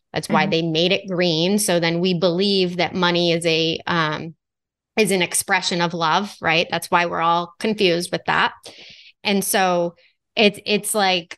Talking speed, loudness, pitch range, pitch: 175 wpm, -19 LUFS, 165-190 Hz, 175 Hz